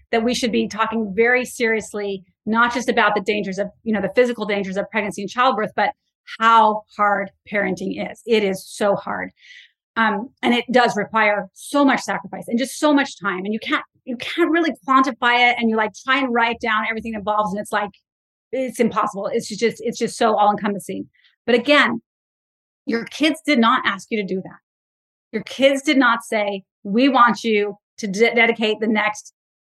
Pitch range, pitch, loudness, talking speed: 205-245 Hz, 225 Hz, -19 LUFS, 195 wpm